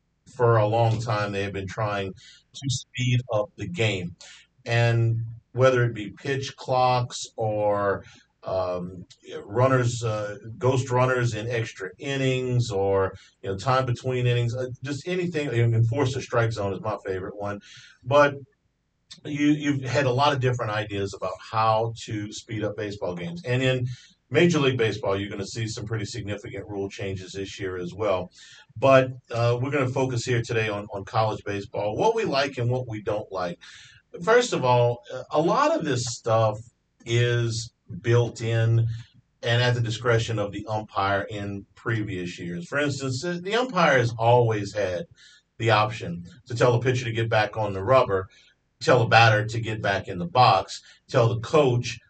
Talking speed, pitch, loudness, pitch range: 175 wpm, 115 Hz, -25 LUFS, 105-130 Hz